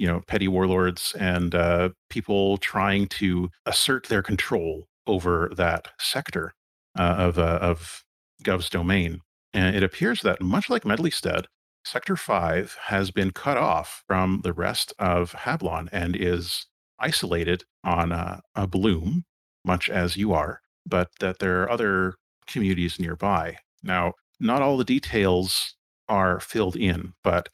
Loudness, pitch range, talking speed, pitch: -25 LUFS, 85-95 Hz, 145 wpm, 90 Hz